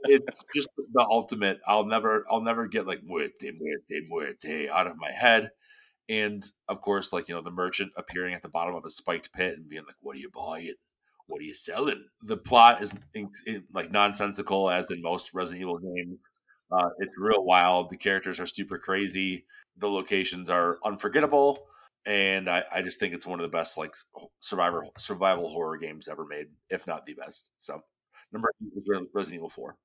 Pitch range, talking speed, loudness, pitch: 90-120 Hz, 195 wpm, -28 LUFS, 100 Hz